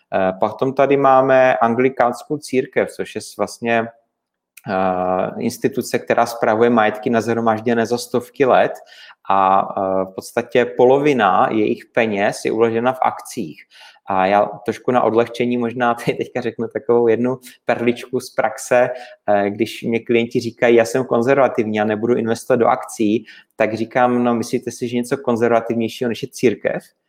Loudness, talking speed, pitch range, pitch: -18 LUFS, 140 wpm, 110-125 Hz, 120 Hz